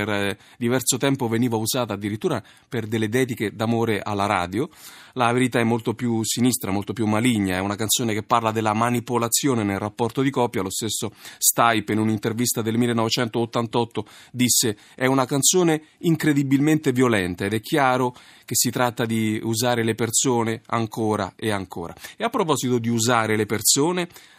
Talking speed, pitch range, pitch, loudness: 160 wpm, 110-125 Hz, 115 Hz, -22 LUFS